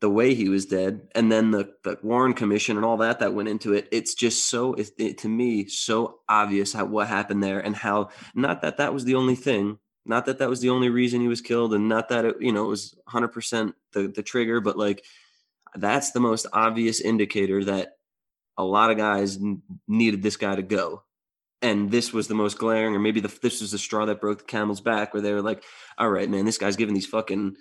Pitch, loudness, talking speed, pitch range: 105 Hz, -24 LUFS, 235 wpm, 100-115 Hz